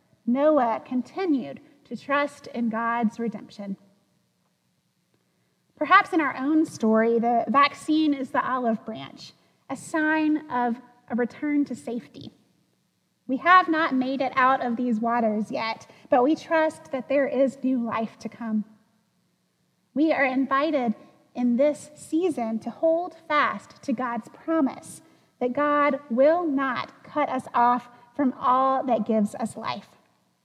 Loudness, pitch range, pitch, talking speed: -24 LUFS, 230-290 Hz, 255 Hz, 140 wpm